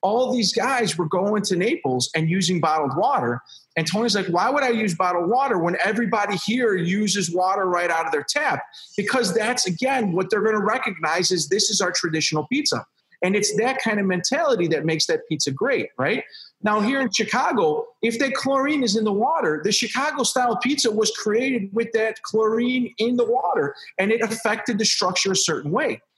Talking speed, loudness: 200 wpm, -21 LUFS